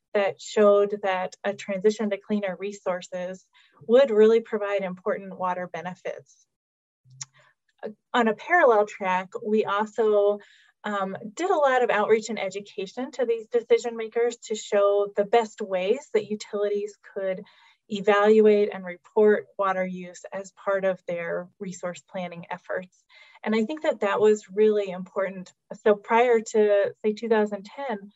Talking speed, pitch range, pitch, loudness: 140 wpm, 190-220 Hz, 205 Hz, -24 LUFS